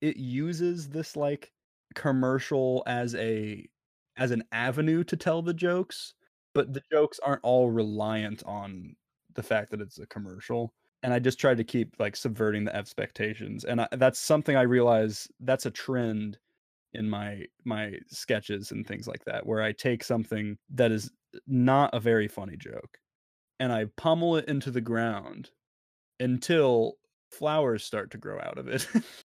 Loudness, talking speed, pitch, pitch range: -29 LUFS, 165 wpm, 125 Hz, 110-140 Hz